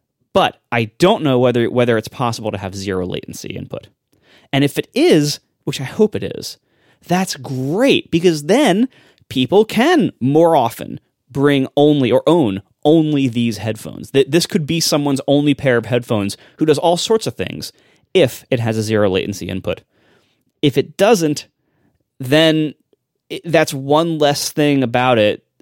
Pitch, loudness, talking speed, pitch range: 135 Hz, -16 LUFS, 160 wpm, 120-155 Hz